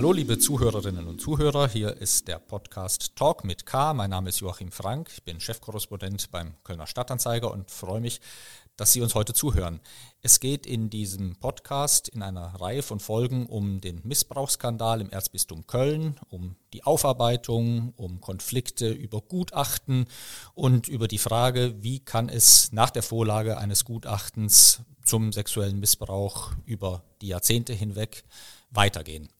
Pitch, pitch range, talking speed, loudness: 110 Hz, 100-125 Hz, 150 wpm, -24 LUFS